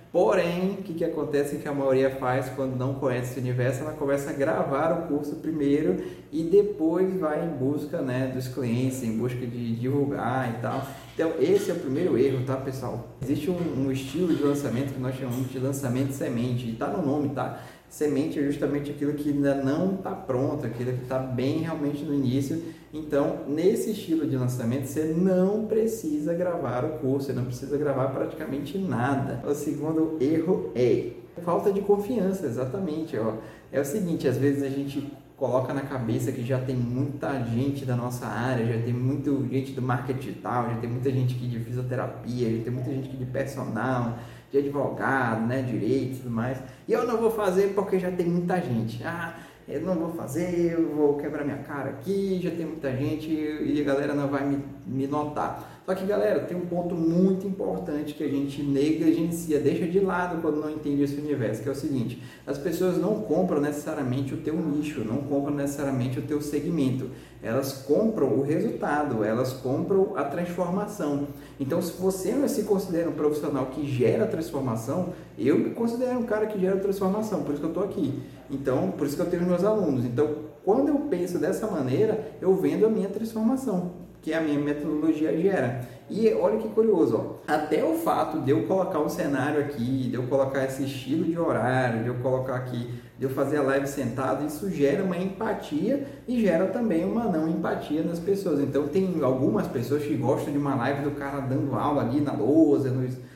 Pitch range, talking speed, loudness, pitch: 130-165 Hz, 195 wpm, -27 LUFS, 145 Hz